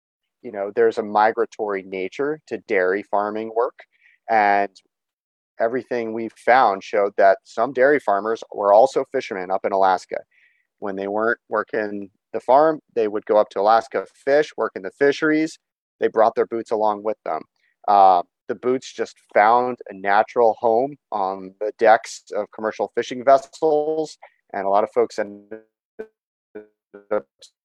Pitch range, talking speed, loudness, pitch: 100-140 Hz, 155 wpm, -20 LUFS, 110 Hz